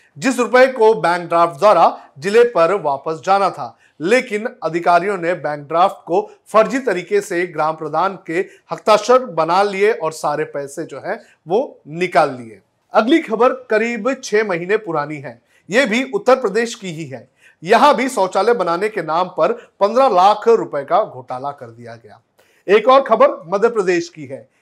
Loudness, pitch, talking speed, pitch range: -16 LUFS, 200 Hz, 170 wpm, 165-255 Hz